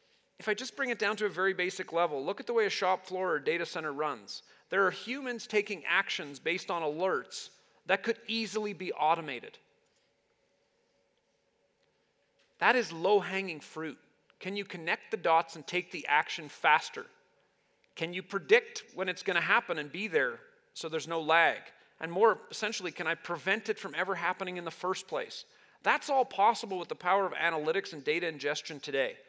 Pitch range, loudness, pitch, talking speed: 180-295 Hz, -31 LUFS, 200 Hz, 185 wpm